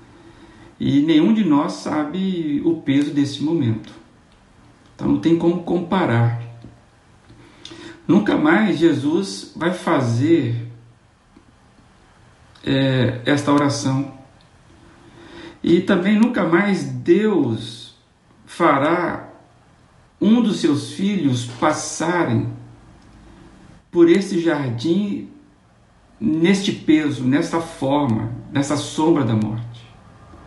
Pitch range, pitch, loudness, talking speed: 120-170 Hz, 145 Hz, -19 LUFS, 85 wpm